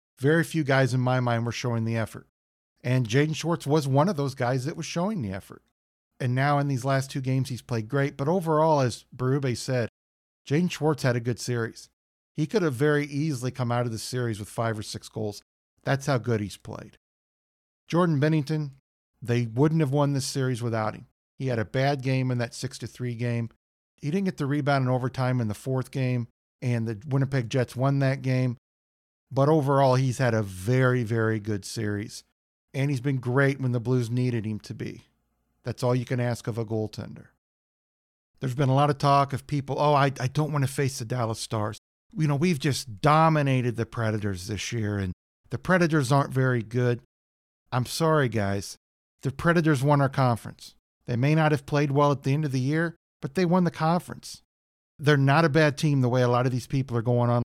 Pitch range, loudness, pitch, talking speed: 115-145 Hz, -26 LUFS, 130 Hz, 215 wpm